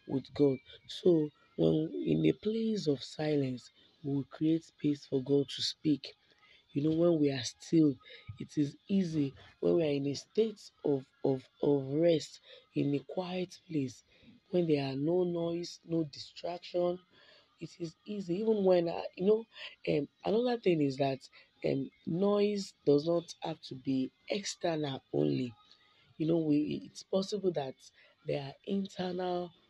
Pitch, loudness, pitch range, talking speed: 155 Hz, -33 LUFS, 140-180 Hz, 160 wpm